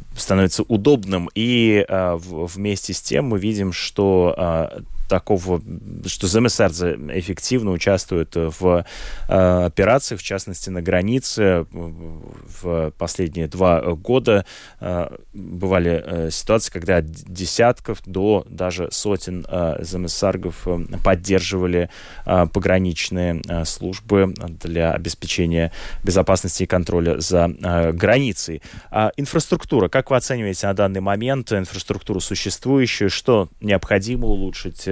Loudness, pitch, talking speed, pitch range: -20 LUFS, 95 Hz, 115 wpm, 85-105 Hz